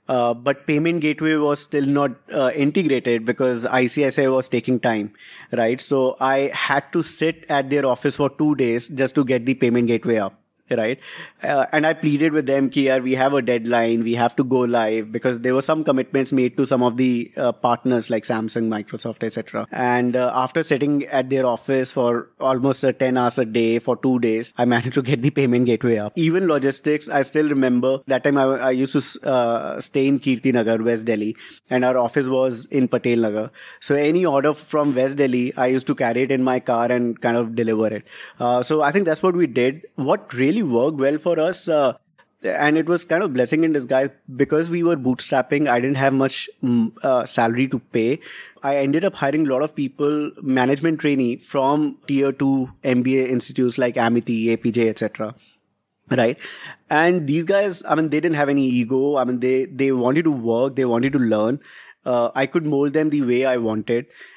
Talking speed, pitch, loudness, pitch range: 205 wpm, 130 Hz, -20 LUFS, 120-145 Hz